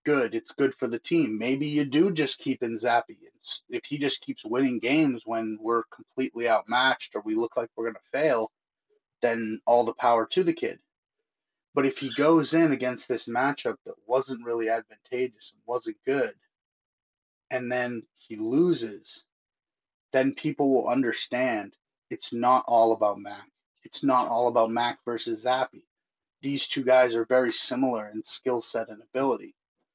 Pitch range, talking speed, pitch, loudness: 115-160 Hz, 170 wpm, 130 Hz, -26 LUFS